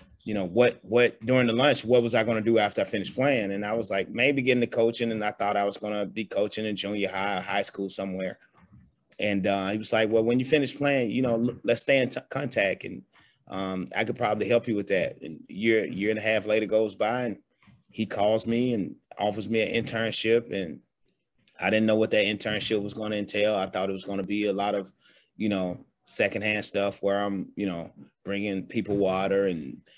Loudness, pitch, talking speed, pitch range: -27 LUFS, 105 Hz, 240 wpm, 100-115 Hz